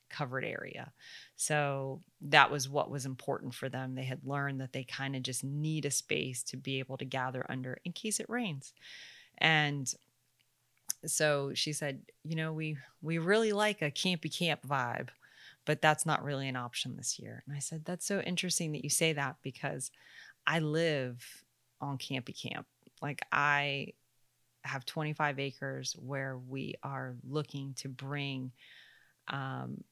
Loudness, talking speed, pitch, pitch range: -34 LUFS, 160 wpm, 140 Hz, 130-155 Hz